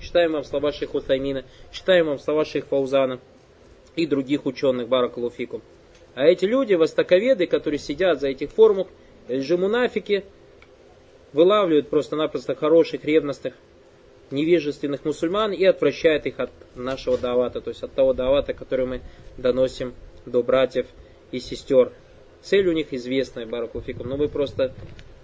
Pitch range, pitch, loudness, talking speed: 130-180 Hz, 145 Hz, -22 LUFS, 135 wpm